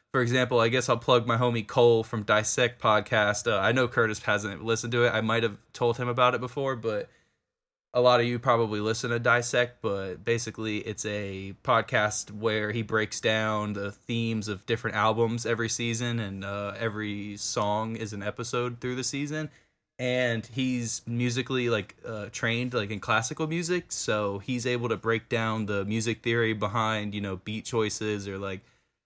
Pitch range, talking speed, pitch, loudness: 105-120 Hz, 185 wpm, 115 Hz, -27 LUFS